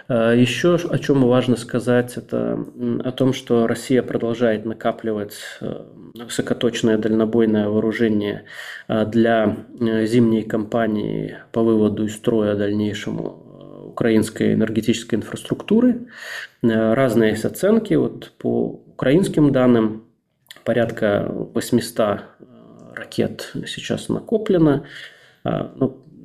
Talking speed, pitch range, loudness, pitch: 85 wpm, 110-125 Hz, -20 LUFS, 115 Hz